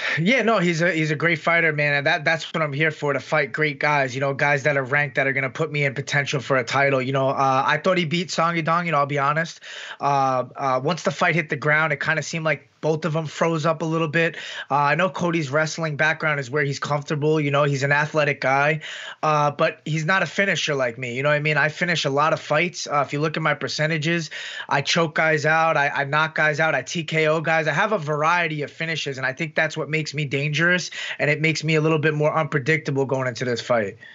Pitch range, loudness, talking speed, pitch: 145-165 Hz, -21 LUFS, 265 wpm, 155 Hz